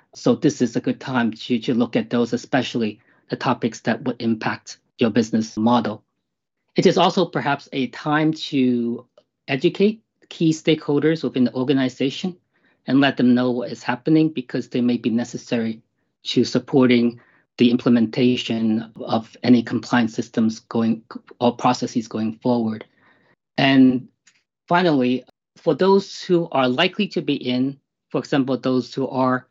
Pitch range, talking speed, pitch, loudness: 120-155 Hz, 150 wpm, 125 Hz, -21 LUFS